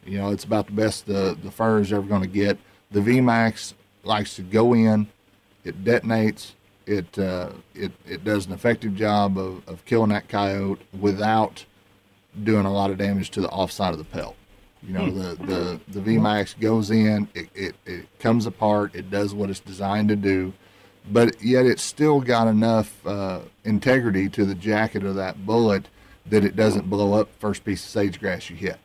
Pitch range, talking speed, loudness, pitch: 100-110 Hz, 195 wpm, -23 LUFS, 100 Hz